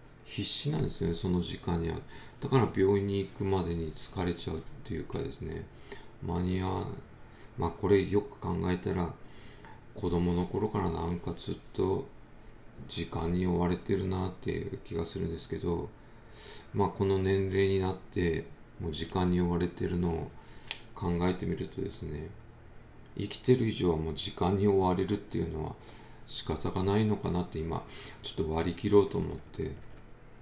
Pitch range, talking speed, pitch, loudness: 85-105 Hz, 325 characters per minute, 95 Hz, -32 LUFS